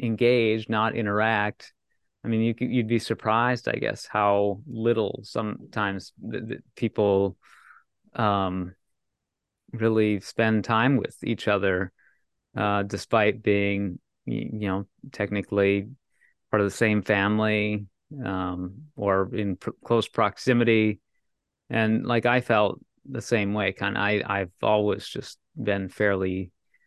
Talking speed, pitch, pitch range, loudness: 125 wpm, 105 Hz, 100-115 Hz, -25 LUFS